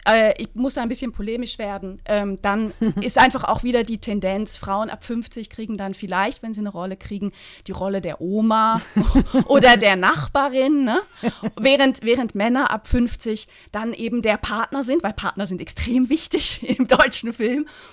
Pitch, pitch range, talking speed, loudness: 225 Hz, 205-255 Hz, 170 wpm, -20 LUFS